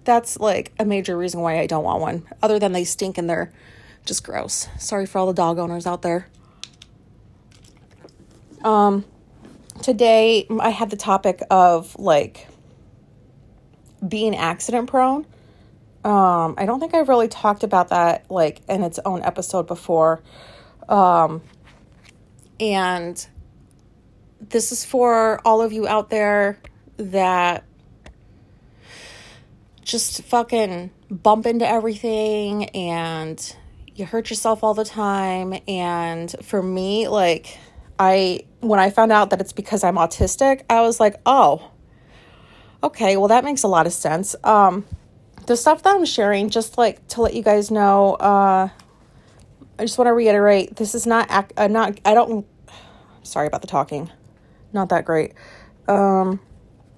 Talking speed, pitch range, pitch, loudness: 140 wpm, 175-220 Hz, 195 Hz, -19 LUFS